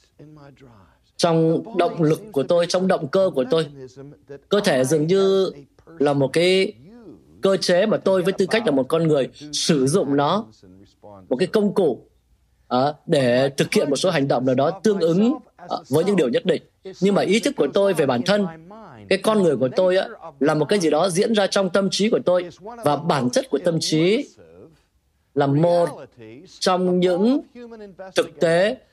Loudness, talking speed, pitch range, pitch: -20 LUFS, 190 wpm, 140-195 Hz, 170 Hz